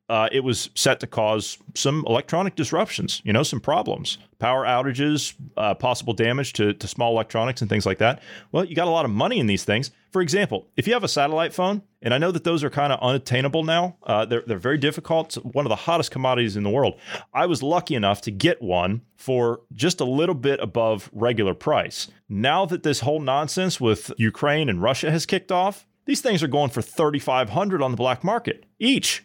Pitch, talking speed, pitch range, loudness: 140 Hz, 215 wpm, 115-170 Hz, -23 LUFS